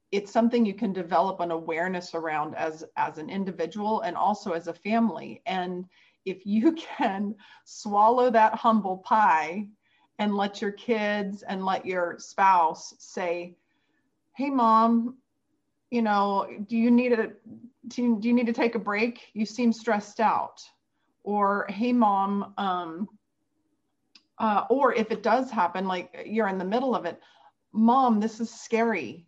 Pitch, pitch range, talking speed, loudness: 215 Hz, 190-235 Hz, 155 wpm, -26 LUFS